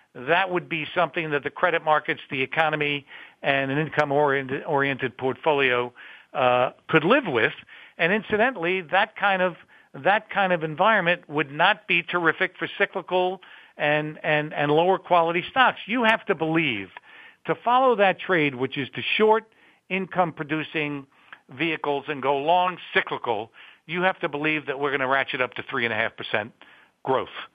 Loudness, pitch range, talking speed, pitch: -23 LUFS, 145-185 Hz, 160 wpm, 160 Hz